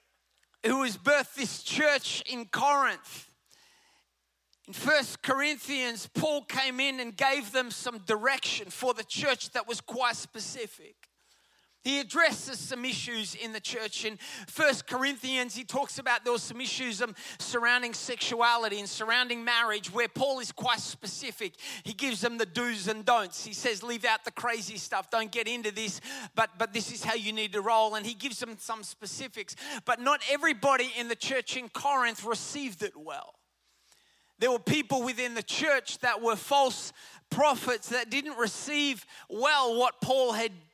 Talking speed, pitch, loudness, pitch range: 165 wpm, 245 Hz, -29 LUFS, 225-270 Hz